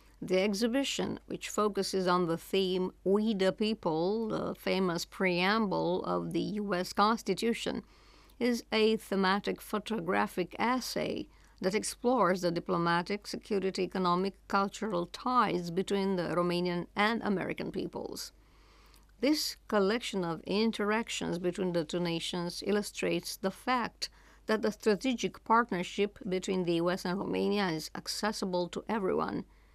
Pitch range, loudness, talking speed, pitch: 180-215 Hz, -32 LUFS, 120 wpm, 195 Hz